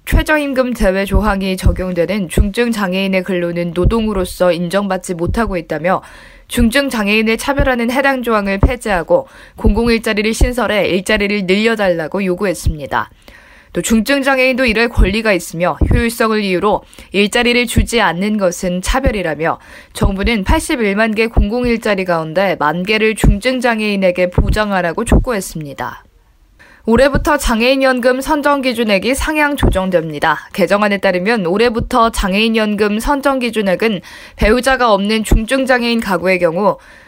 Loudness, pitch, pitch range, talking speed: -14 LUFS, 215 Hz, 185-240 Hz, 340 characters per minute